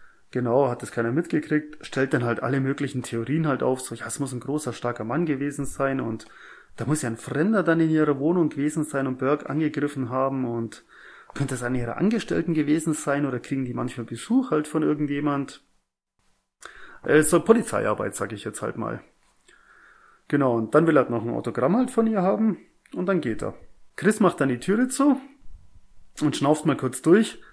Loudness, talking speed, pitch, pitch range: -24 LUFS, 200 wpm, 145 Hz, 125-160 Hz